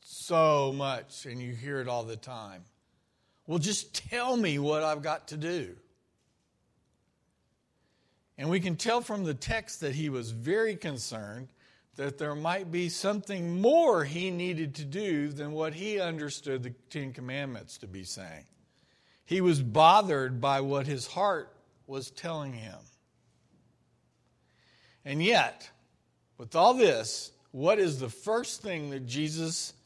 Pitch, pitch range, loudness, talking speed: 150 Hz, 130-175 Hz, -30 LUFS, 145 wpm